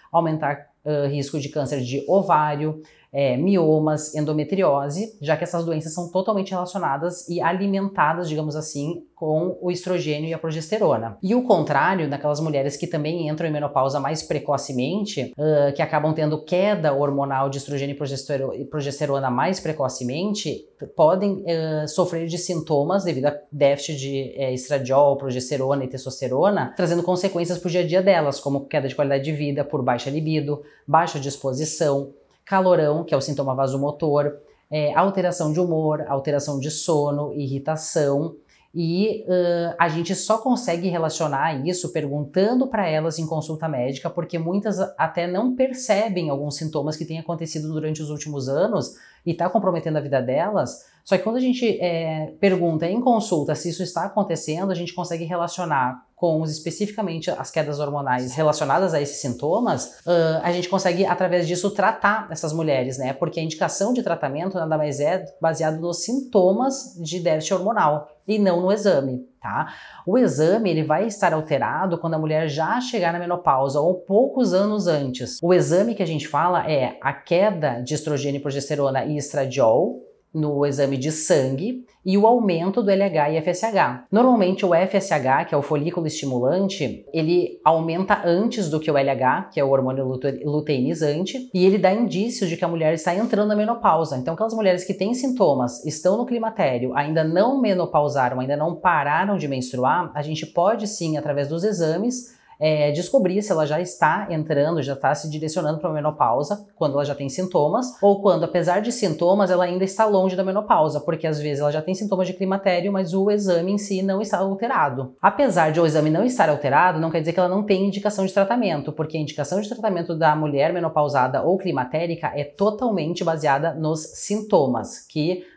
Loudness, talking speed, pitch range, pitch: -22 LUFS, 175 wpm, 145-185 Hz, 160 Hz